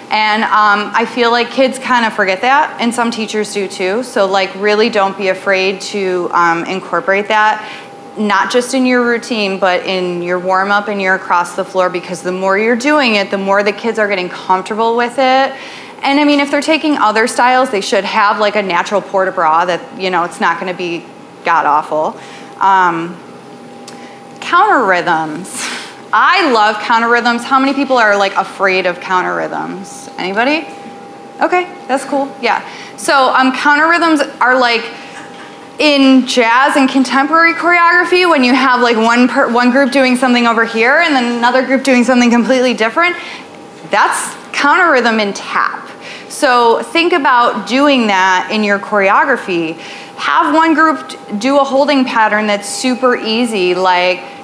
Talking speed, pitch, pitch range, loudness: 170 wpm, 230 Hz, 195-265 Hz, -12 LUFS